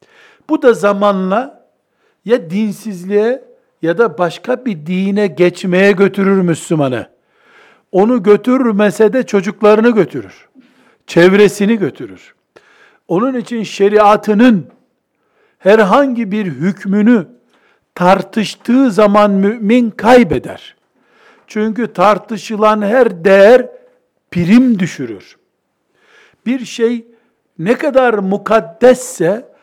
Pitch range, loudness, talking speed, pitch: 195-240 Hz, -12 LUFS, 85 wpm, 215 Hz